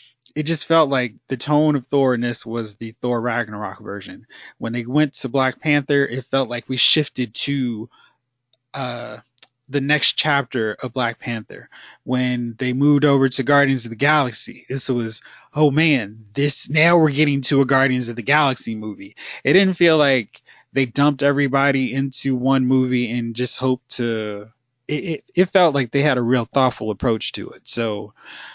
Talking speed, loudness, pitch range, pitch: 180 wpm, -19 LUFS, 120-145 Hz, 130 Hz